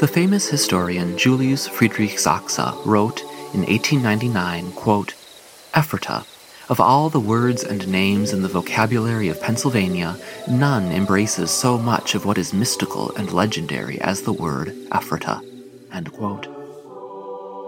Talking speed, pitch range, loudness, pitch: 120 wpm, 95-130 Hz, -20 LUFS, 105 Hz